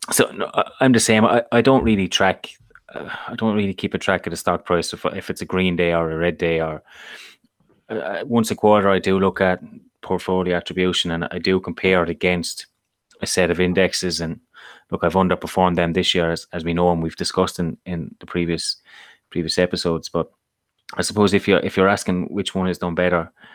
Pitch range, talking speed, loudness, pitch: 85-95 Hz, 215 wpm, -20 LUFS, 90 Hz